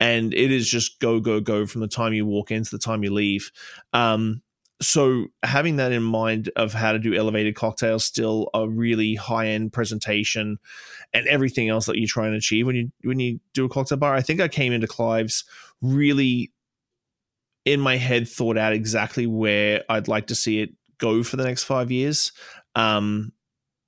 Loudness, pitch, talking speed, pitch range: -22 LUFS, 115 Hz, 195 wpm, 110-125 Hz